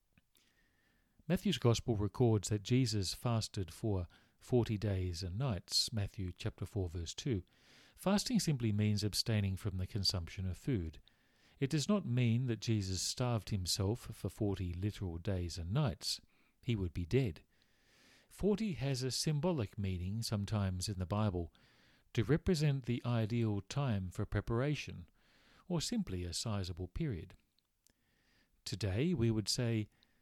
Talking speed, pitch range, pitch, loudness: 135 wpm, 95-125 Hz, 110 Hz, -37 LUFS